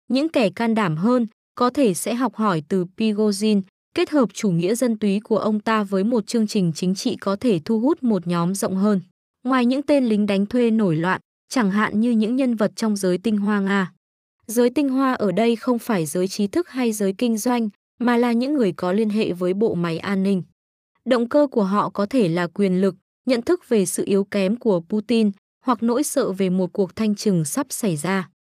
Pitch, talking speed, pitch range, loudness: 215 Hz, 225 wpm, 195-245 Hz, -21 LUFS